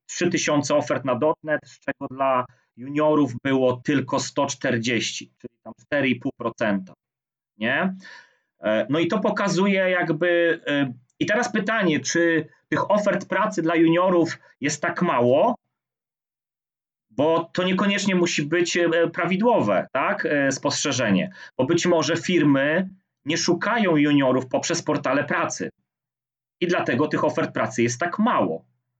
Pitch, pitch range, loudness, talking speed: 155 Hz, 135-175 Hz, -22 LUFS, 120 wpm